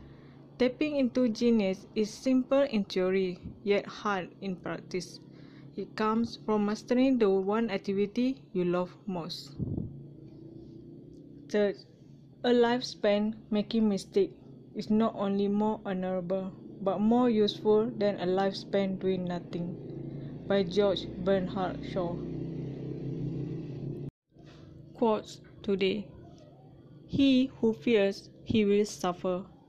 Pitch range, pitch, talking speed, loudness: 160-215 Hz, 195 Hz, 105 wpm, -30 LUFS